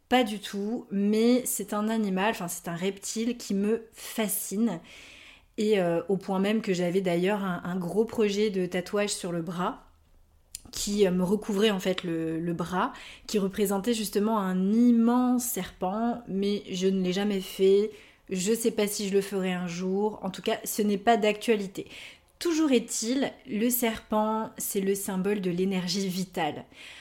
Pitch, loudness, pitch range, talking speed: 205 Hz, -28 LUFS, 185-220 Hz, 175 wpm